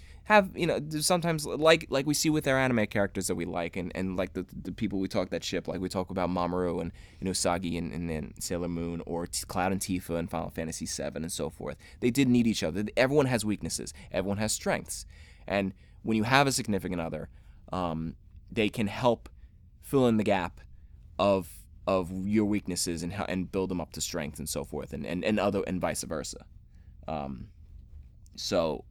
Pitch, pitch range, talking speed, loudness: 90 Hz, 85-105 Hz, 210 wpm, -30 LUFS